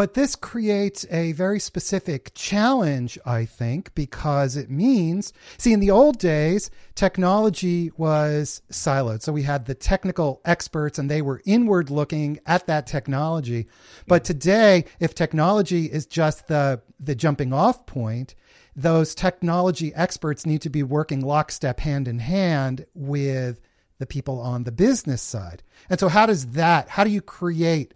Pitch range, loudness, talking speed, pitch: 140-185 Hz, -22 LUFS, 155 wpm, 155 Hz